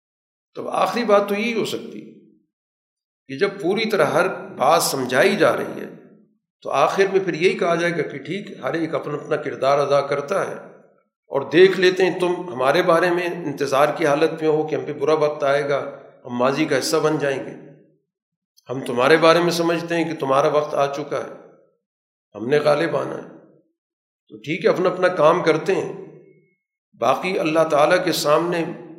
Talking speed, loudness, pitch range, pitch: 195 wpm, -20 LUFS, 145-185 Hz, 165 Hz